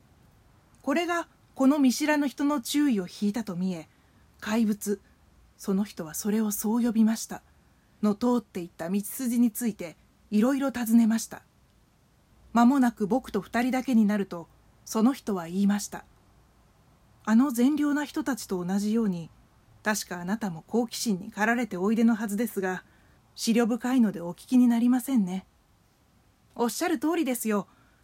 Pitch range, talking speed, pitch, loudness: 195-245 Hz, 305 characters per minute, 220 Hz, -27 LUFS